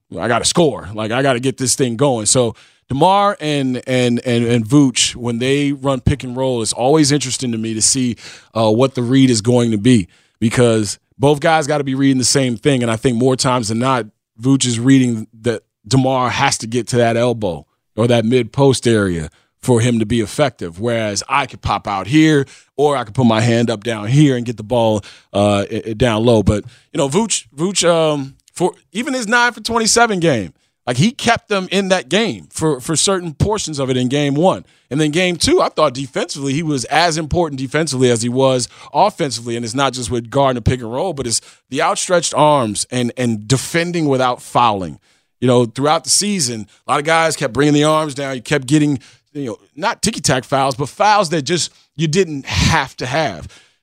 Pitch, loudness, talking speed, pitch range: 130 Hz, -16 LUFS, 220 wpm, 120-150 Hz